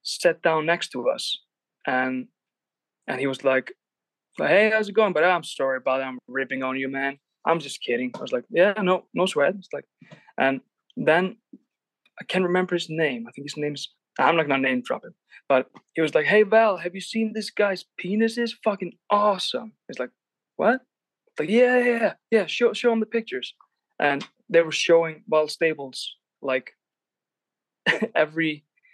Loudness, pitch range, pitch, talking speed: -24 LUFS, 145-220 Hz, 175 Hz, 185 wpm